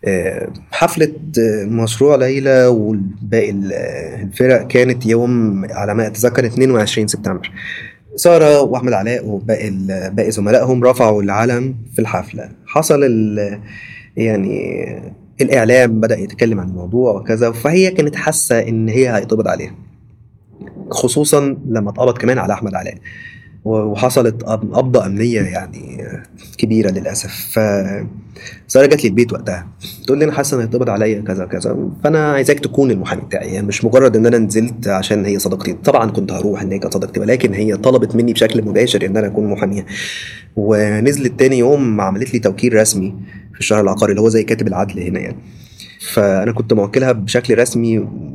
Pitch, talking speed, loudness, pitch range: 110 Hz, 145 wpm, -15 LUFS, 105-125 Hz